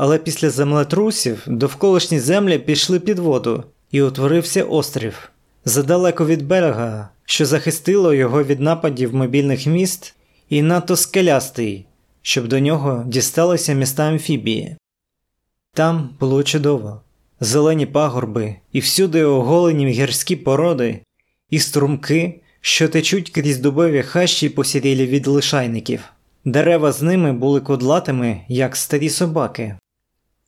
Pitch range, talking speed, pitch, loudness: 130-165 Hz, 115 wpm, 145 Hz, -17 LUFS